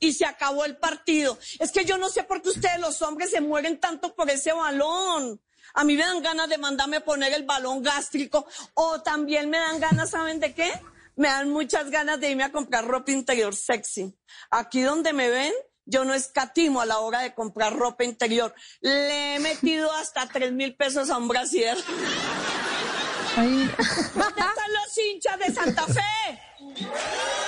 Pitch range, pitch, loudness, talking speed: 265-325 Hz, 295 Hz, -25 LUFS, 180 wpm